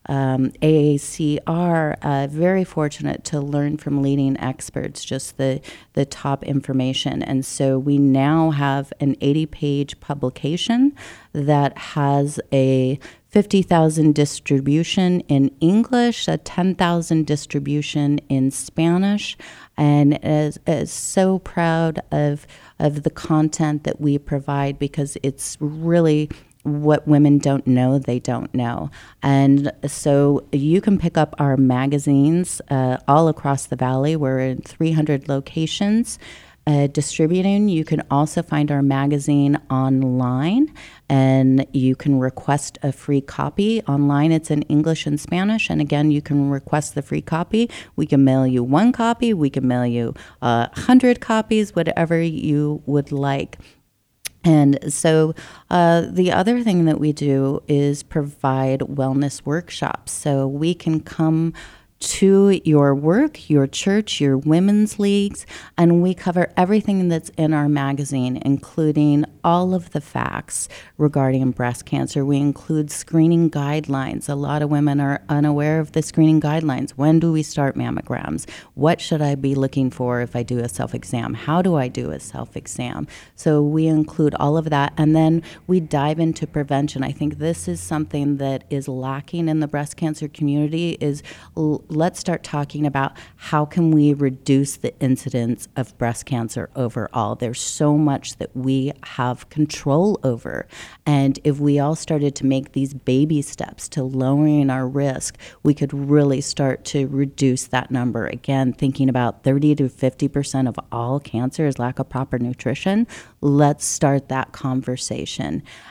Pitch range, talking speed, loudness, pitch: 135-160 Hz, 150 wpm, -20 LUFS, 145 Hz